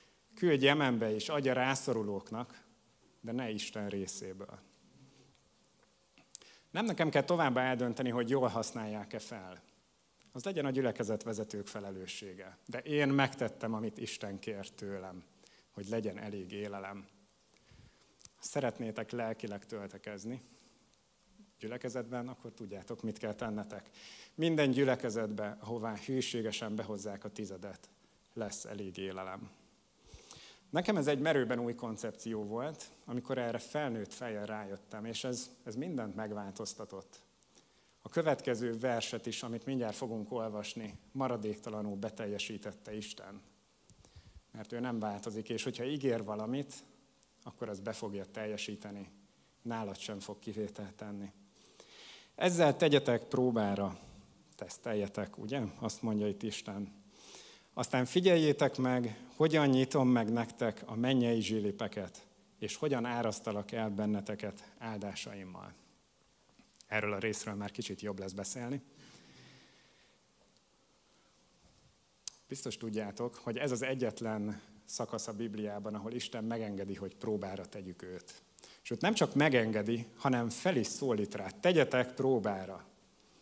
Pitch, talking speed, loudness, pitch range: 110 Hz, 115 wpm, -36 LUFS, 105-125 Hz